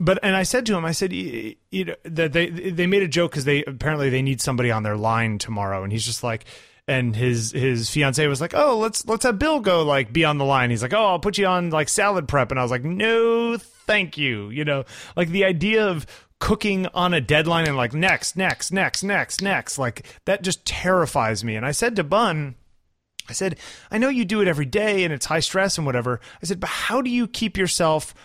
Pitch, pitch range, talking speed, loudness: 165 Hz, 135-195 Hz, 240 wpm, -21 LUFS